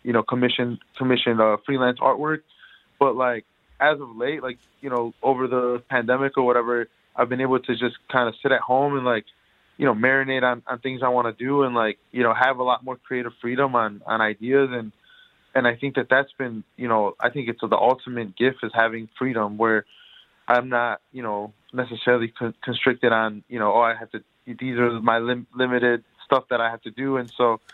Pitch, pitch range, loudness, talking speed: 125 Hz, 115-130 Hz, -23 LUFS, 220 wpm